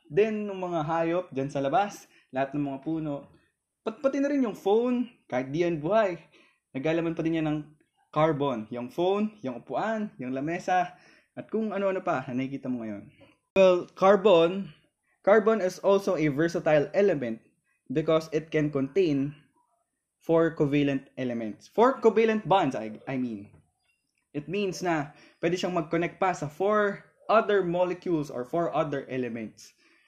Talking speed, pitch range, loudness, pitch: 150 wpm, 140-195 Hz, -27 LUFS, 165 Hz